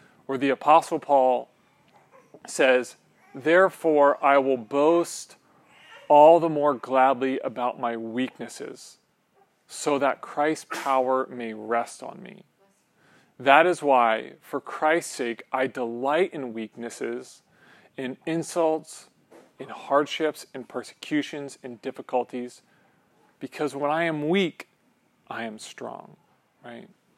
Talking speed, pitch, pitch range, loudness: 115 wpm, 135 Hz, 125-155 Hz, -24 LUFS